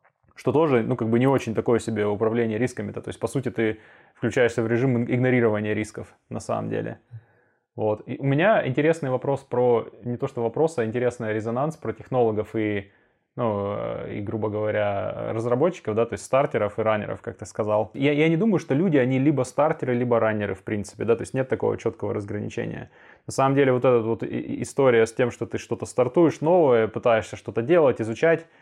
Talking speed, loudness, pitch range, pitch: 195 wpm, -24 LUFS, 110-130 Hz, 120 Hz